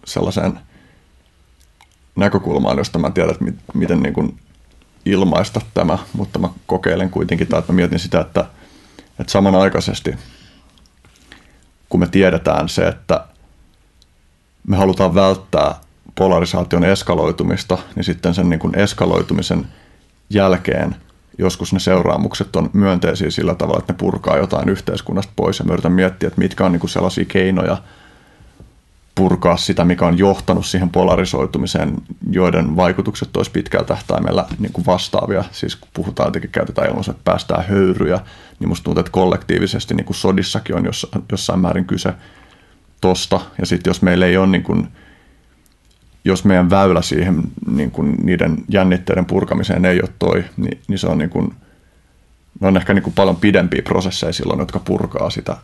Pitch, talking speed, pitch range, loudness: 90 Hz, 145 wpm, 85-95 Hz, -17 LUFS